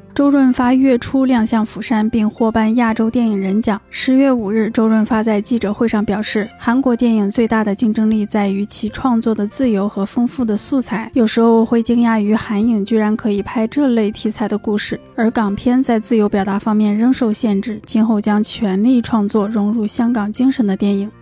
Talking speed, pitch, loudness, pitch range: 305 characters per minute, 225 Hz, -16 LUFS, 210-240 Hz